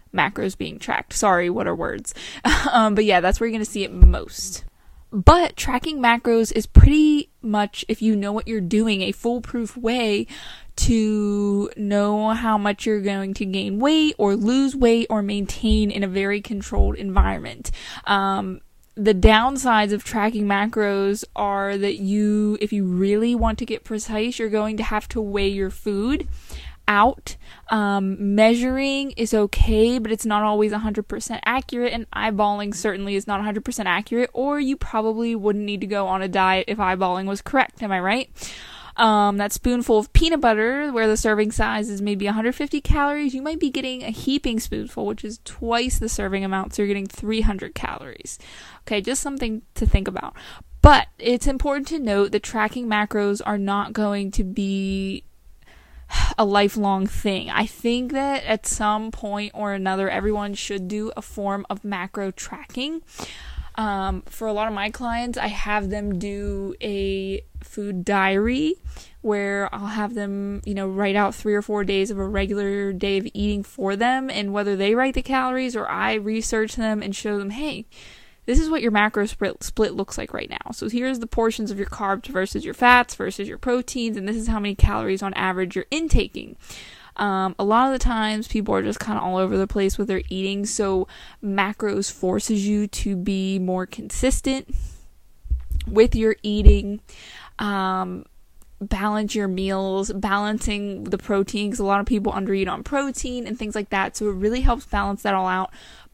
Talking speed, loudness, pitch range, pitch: 180 wpm, -22 LUFS, 200-225 Hz, 210 Hz